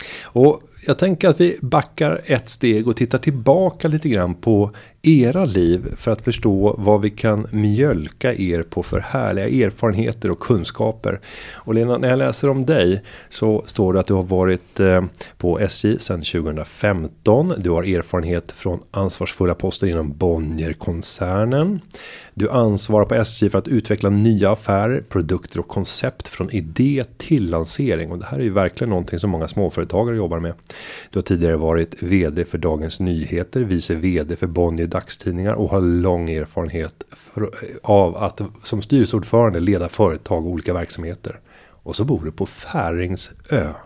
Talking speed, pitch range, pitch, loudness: 160 wpm, 85-115 Hz, 100 Hz, -19 LUFS